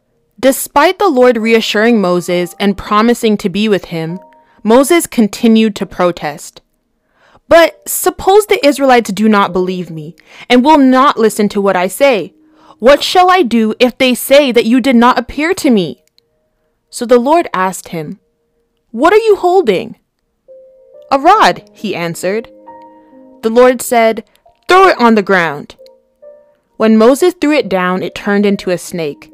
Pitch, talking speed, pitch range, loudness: 230 Hz, 155 wpm, 185-285 Hz, -10 LUFS